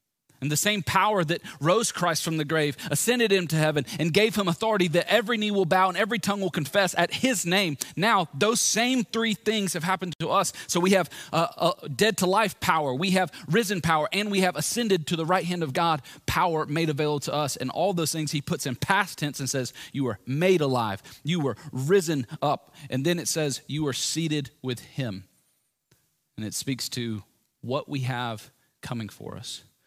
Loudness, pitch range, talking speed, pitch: -25 LUFS, 140-190 Hz, 210 wpm, 165 Hz